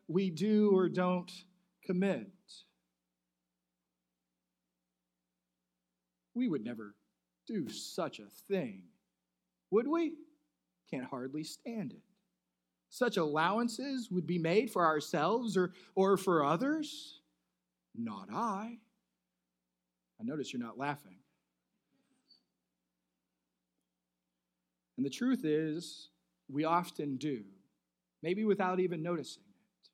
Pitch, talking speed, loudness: 140 Hz, 95 wpm, -35 LUFS